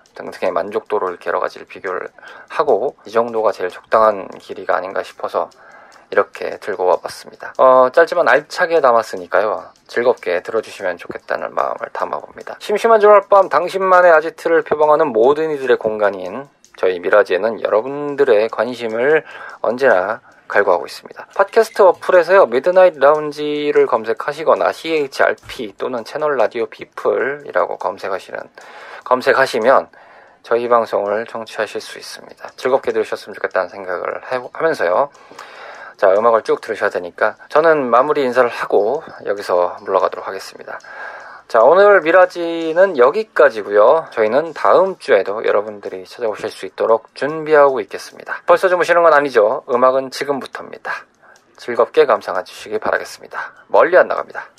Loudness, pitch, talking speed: -16 LUFS, 210 Hz, 365 characters per minute